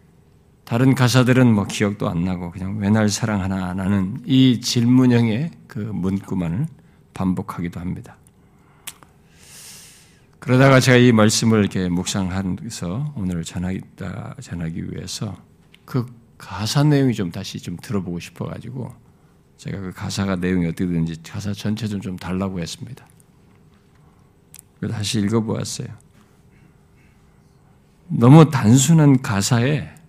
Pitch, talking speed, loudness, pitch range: 105 Hz, 265 characters per minute, -19 LUFS, 95-125 Hz